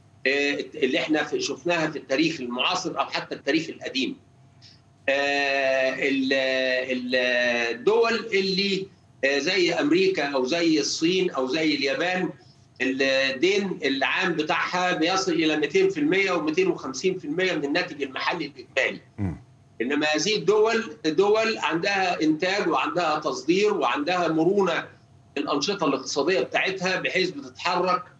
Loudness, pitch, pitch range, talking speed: -24 LUFS, 160 Hz, 135-190 Hz, 100 wpm